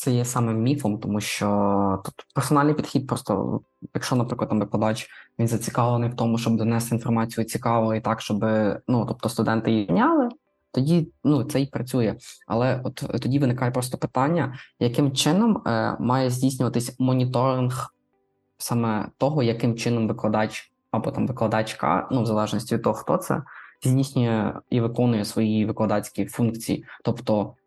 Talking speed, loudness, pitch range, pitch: 150 wpm, -24 LUFS, 110-130 Hz, 120 Hz